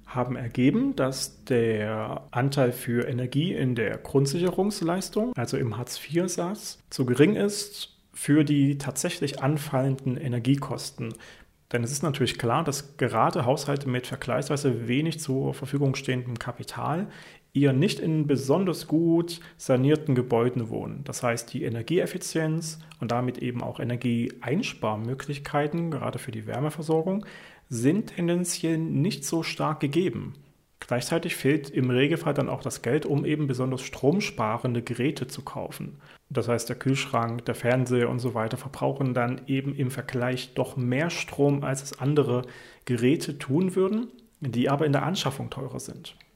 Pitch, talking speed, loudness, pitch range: 135 Hz, 140 wpm, -27 LUFS, 125-160 Hz